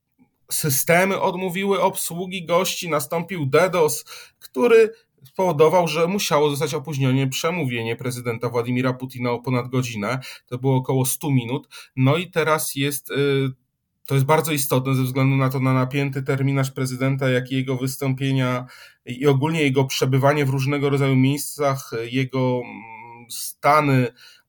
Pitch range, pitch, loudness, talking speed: 130-155 Hz, 135 Hz, -21 LUFS, 130 wpm